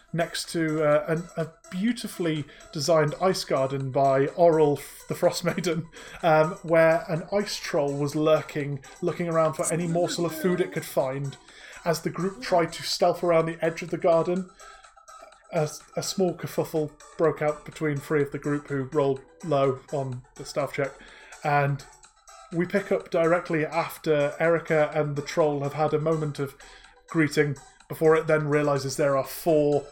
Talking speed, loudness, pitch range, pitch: 170 wpm, -26 LUFS, 145-170 Hz, 160 Hz